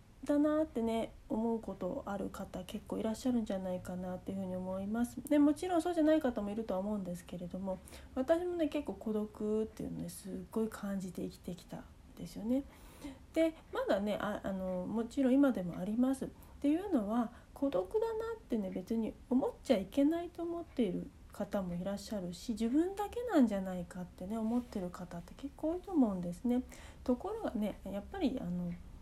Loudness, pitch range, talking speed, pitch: -36 LUFS, 195-285 Hz, 405 characters per minute, 225 Hz